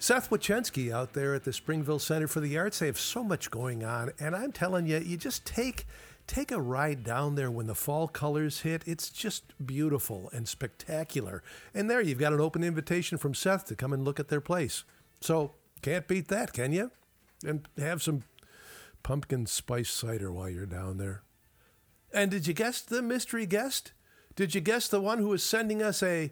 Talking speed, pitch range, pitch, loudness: 200 wpm, 135-195 Hz, 155 Hz, -32 LUFS